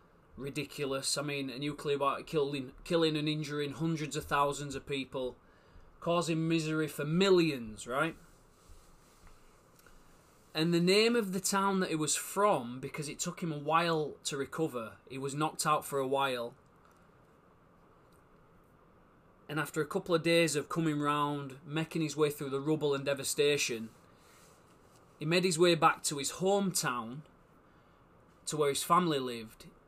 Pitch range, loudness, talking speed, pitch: 140-165 Hz, -32 LUFS, 150 wpm, 150 Hz